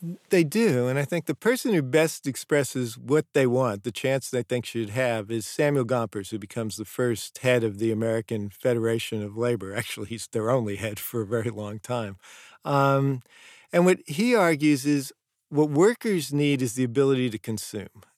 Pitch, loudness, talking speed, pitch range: 125 Hz, -25 LUFS, 190 wpm, 115-145 Hz